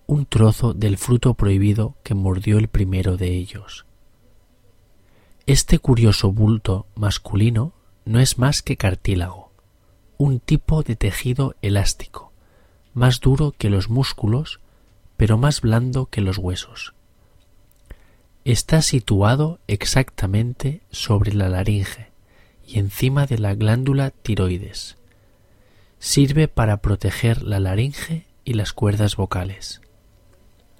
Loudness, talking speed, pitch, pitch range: -20 LUFS, 110 wpm, 105 Hz, 95-125 Hz